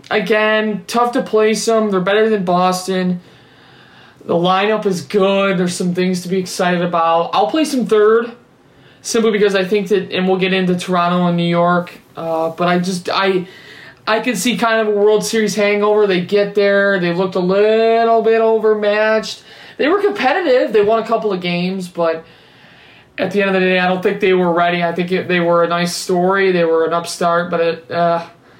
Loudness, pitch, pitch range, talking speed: -15 LUFS, 190 Hz, 175-215 Hz, 205 wpm